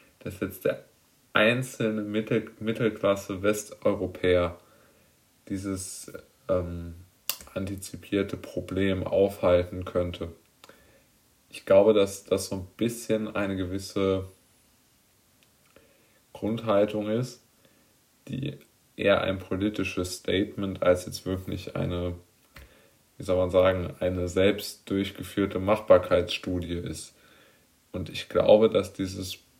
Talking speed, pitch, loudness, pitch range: 95 wpm, 95 Hz, -27 LUFS, 90-105 Hz